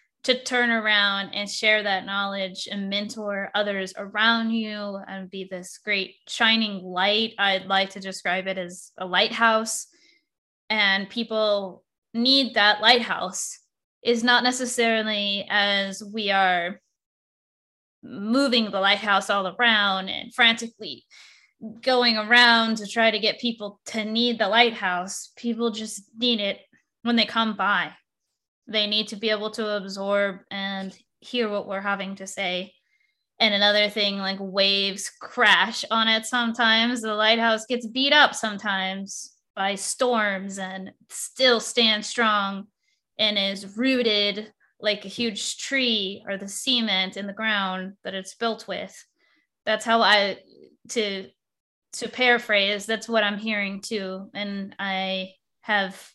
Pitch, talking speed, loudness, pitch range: 210 Hz, 140 wpm, -22 LUFS, 195-230 Hz